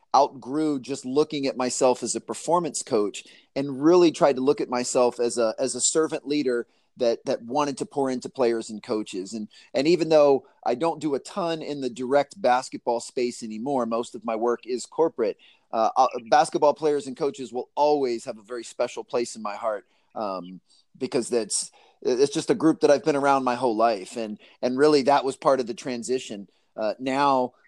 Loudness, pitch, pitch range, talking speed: -24 LUFS, 135 Hz, 120-150 Hz, 200 wpm